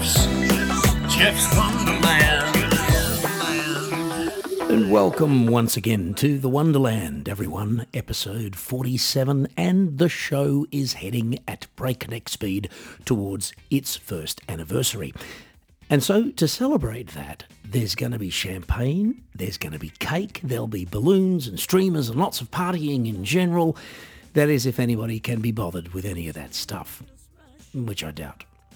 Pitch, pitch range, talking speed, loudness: 120 Hz, 100-150 Hz, 130 wpm, -23 LUFS